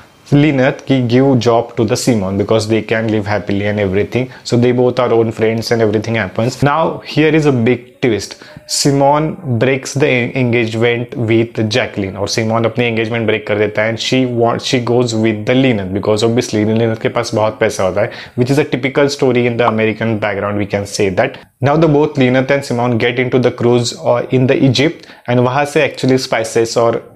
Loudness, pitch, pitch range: -14 LUFS, 120 Hz, 110-130 Hz